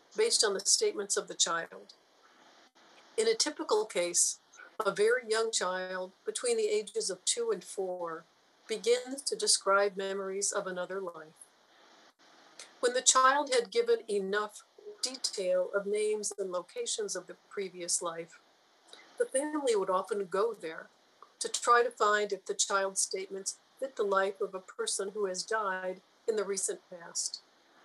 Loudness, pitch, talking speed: -31 LUFS, 225 Hz, 155 wpm